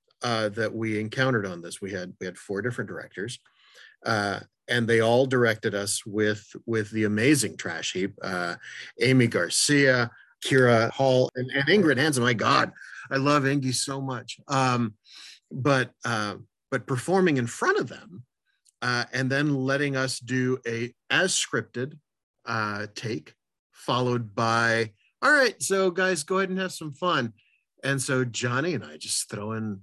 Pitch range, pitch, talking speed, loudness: 115-135 Hz, 125 Hz, 165 wpm, -25 LUFS